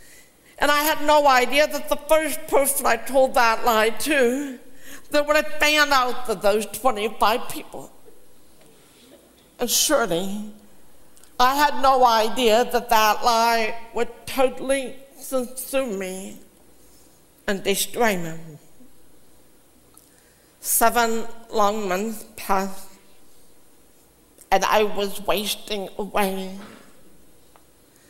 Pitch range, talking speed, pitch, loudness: 210-270 Hz, 105 wpm, 235 Hz, -21 LUFS